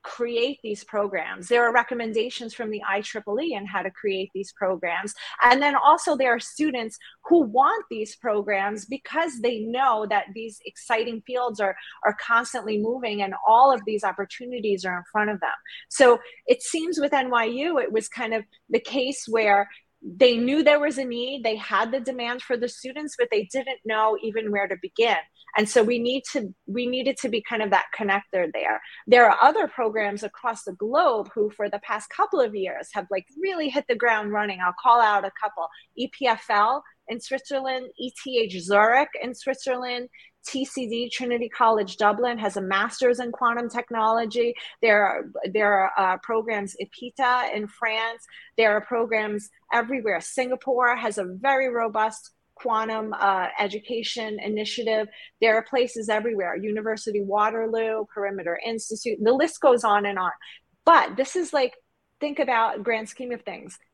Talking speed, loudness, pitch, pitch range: 175 wpm, -24 LUFS, 230 Hz, 210-250 Hz